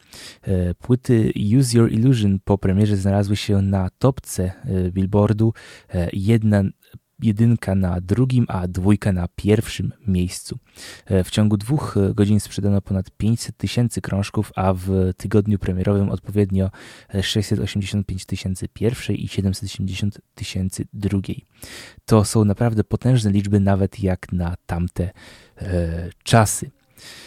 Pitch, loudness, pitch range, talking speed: 100 Hz, -21 LUFS, 95-110 Hz, 115 wpm